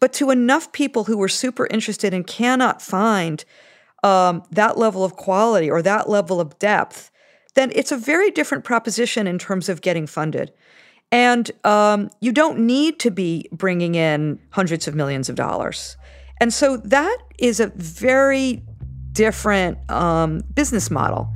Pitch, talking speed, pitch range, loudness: 210 Hz, 155 wpm, 170-245 Hz, -19 LUFS